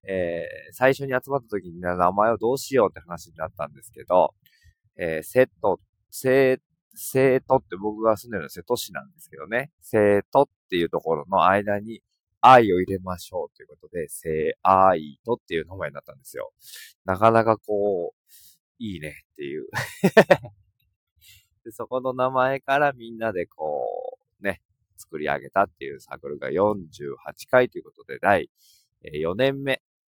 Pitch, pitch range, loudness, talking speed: 125 Hz, 100-145 Hz, -23 LUFS, 305 characters per minute